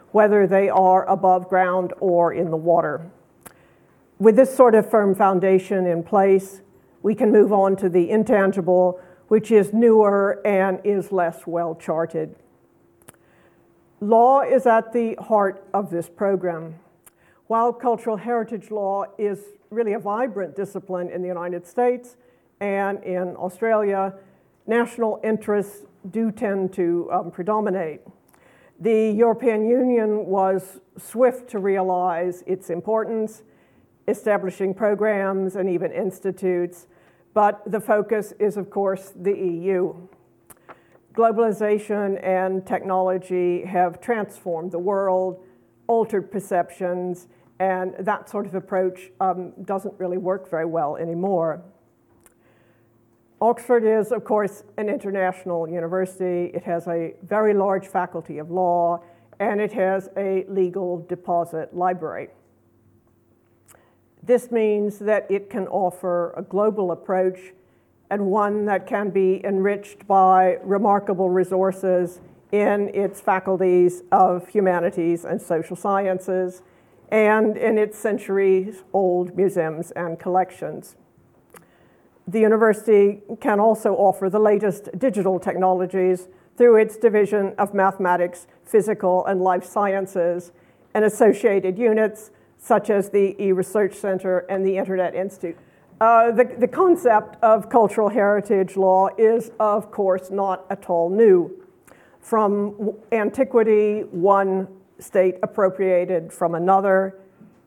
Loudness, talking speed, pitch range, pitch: -21 LUFS, 120 wpm, 180-210 Hz, 195 Hz